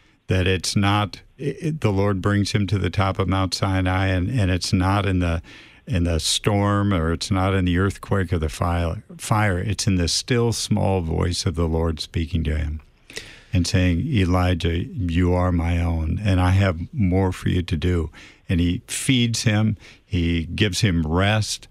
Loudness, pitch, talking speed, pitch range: -22 LUFS, 95 Hz, 190 wpm, 85-105 Hz